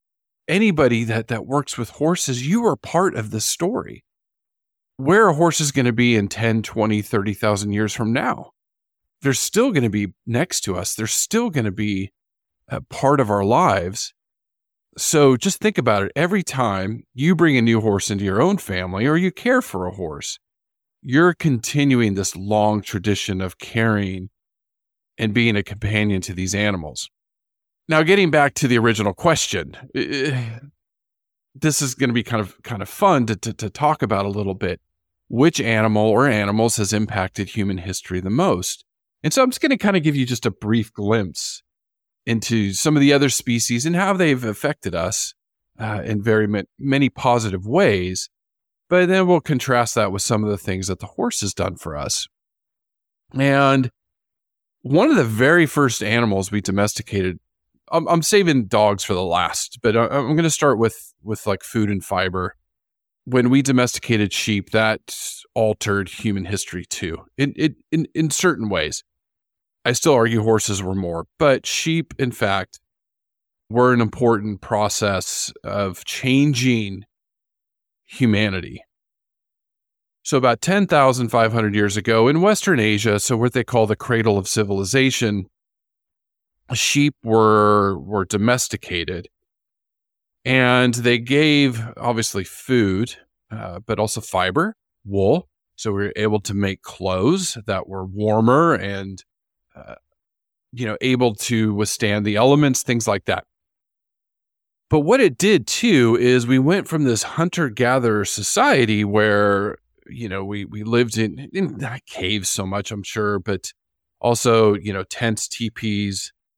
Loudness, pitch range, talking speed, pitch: -19 LUFS, 100-135 Hz, 160 wpm, 110 Hz